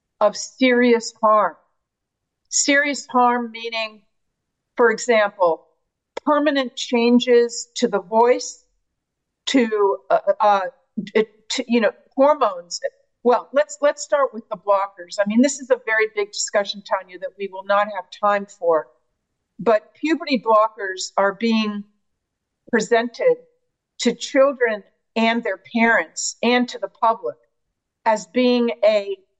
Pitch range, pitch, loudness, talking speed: 205-255 Hz, 230 Hz, -20 LUFS, 125 wpm